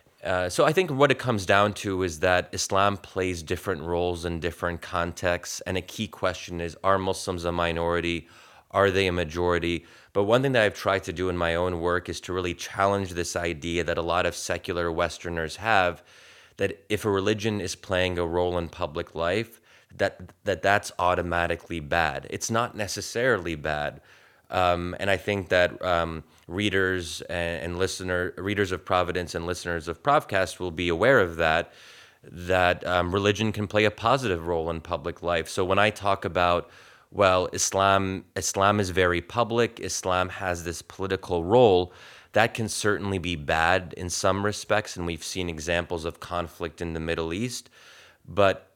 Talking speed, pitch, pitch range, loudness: 175 wpm, 90 Hz, 85-100 Hz, -26 LUFS